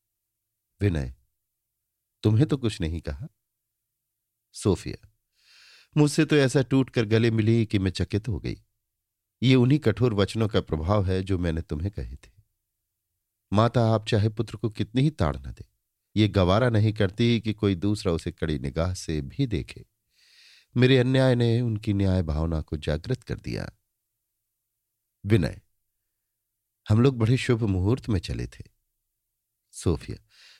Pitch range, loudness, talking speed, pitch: 95-115 Hz, -25 LUFS, 140 wpm, 110 Hz